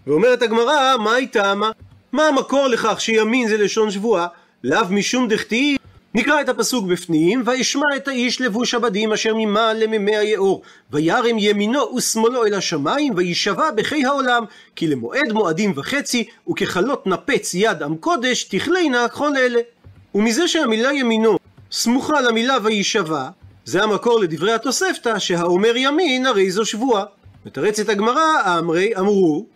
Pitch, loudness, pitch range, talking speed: 225 Hz, -18 LUFS, 205-255 Hz, 140 wpm